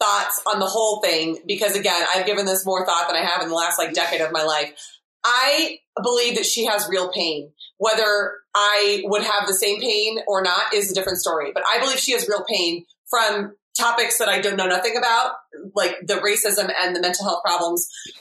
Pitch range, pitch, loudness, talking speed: 175-220 Hz, 200 Hz, -20 LUFS, 215 wpm